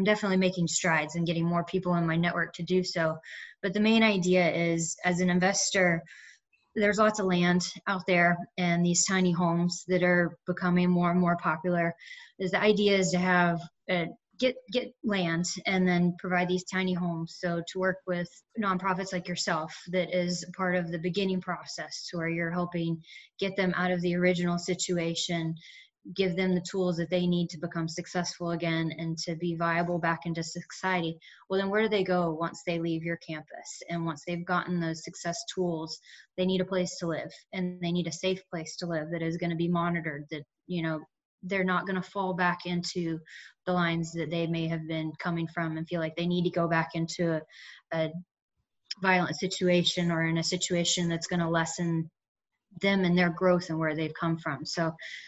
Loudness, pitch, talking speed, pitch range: -29 LUFS, 175 Hz, 200 wpm, 165-185 Hz